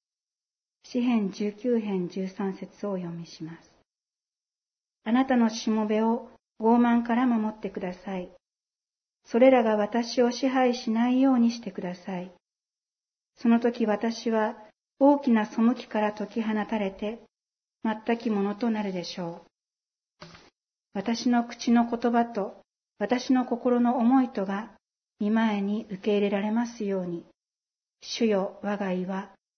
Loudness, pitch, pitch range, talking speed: -26 LUFS, 220 Hz, 200-235 Hz, 240 characters per minute